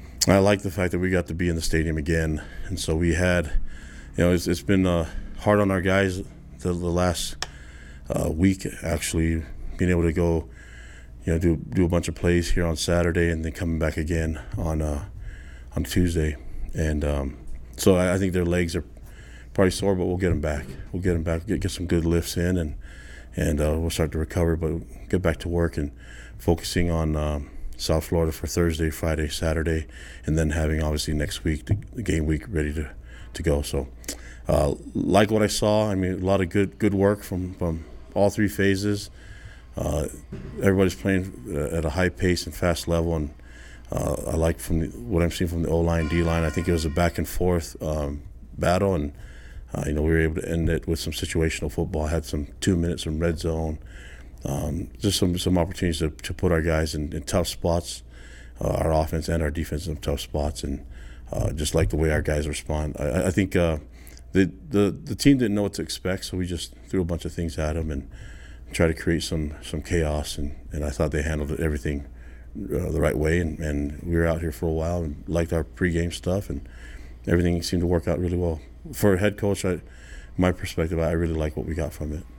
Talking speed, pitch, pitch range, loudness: 220 wpm, 80 Hz, 75-90 Hz, -25 LUFS